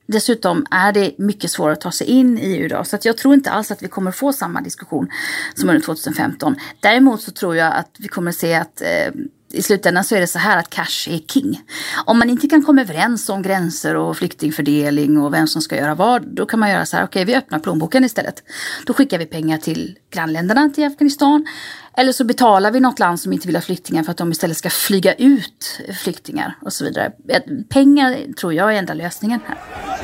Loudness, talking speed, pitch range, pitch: -17 LUFS, 230 wpm, 170-260 Hz, 205 Hz